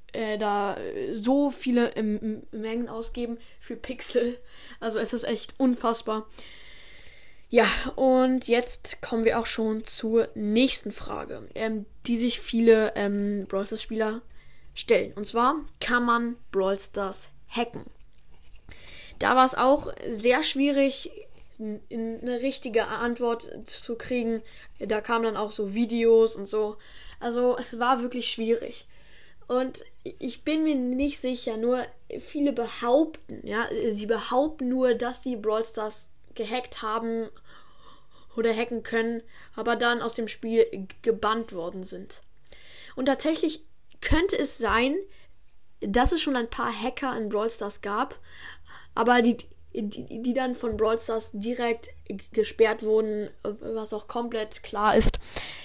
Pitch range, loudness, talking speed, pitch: 220-250 Hz, -27 LUFS, 140 wpm, 230 Hz